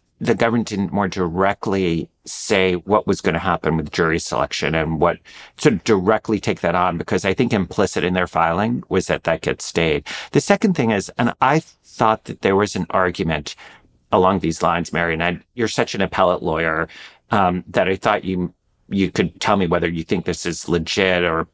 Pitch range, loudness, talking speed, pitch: 85-105 Hz, -19 LUFS, 205 wpm, 90 Hz